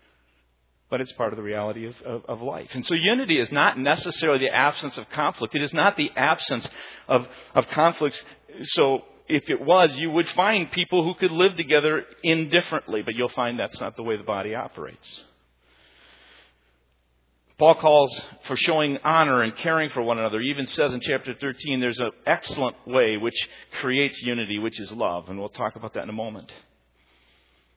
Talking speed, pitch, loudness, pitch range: 185 wpm, 125 Hz, -23 LUFS, 105-160 Hz